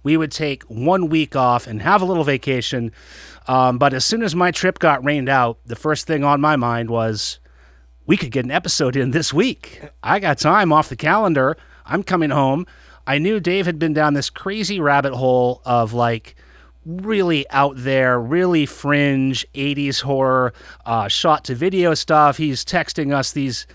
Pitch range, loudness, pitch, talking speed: 130-165 Hz, -18 LUFS, 140 Hz, 185 wpm